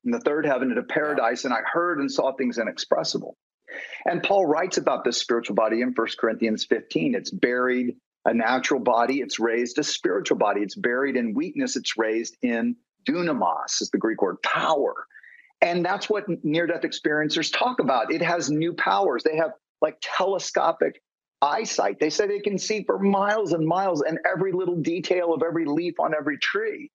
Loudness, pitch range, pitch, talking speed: -24 LUFS, 150-245 Hz, 175 Hz, 185 wpm